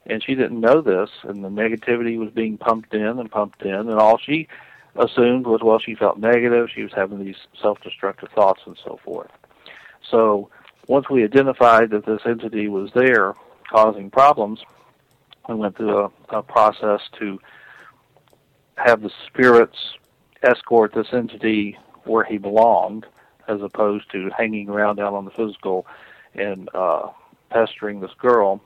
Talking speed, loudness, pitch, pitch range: 155 wpm, -19 LUFS, 110 Hz, 105-115 Hz